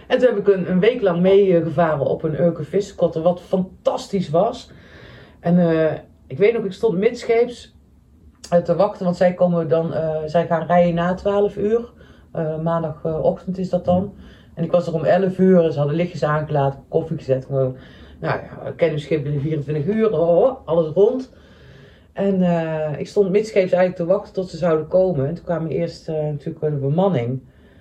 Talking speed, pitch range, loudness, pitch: 190 wpm, 155-190 Hz, -20 LUFS, 170 Hz